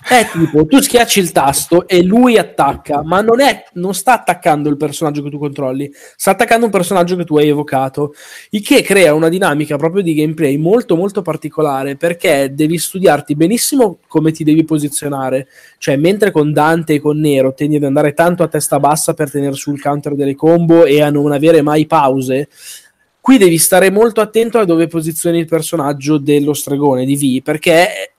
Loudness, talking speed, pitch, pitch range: -12 LUFS, 185 wpm, 155 Hz, 145-180 Hz